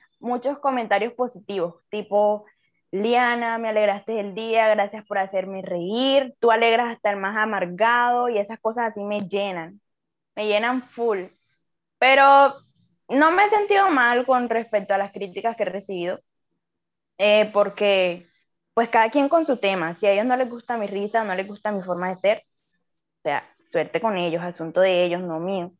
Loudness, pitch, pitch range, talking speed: -22 LUFS, 210 Hz, 195-240 Hz, 175 wpm